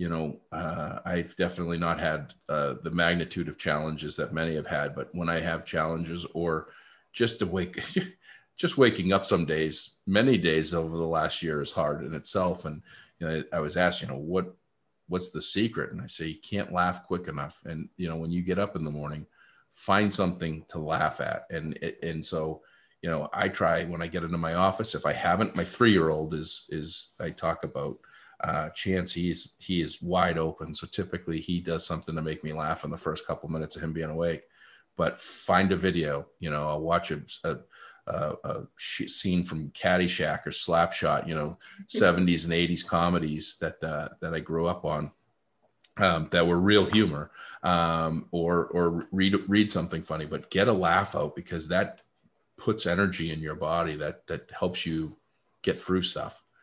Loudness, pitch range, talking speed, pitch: -29 LUFS, 80-90 Hz, 195 wpm, 85 Hz